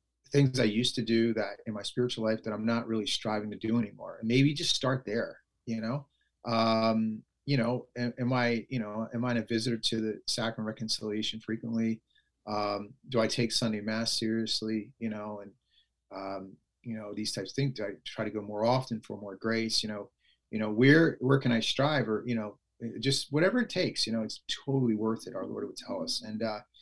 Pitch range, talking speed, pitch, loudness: 110-125 Hz, 220 wpm, 115 Hz, -31 LUFS